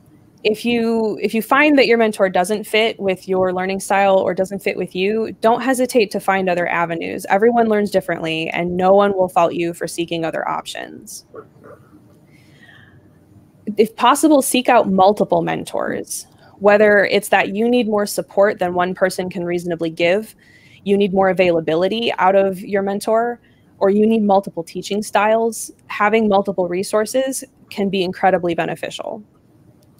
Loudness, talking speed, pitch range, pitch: -17 LUFS, 155 wpm, 185-220 Hz, 200 Hz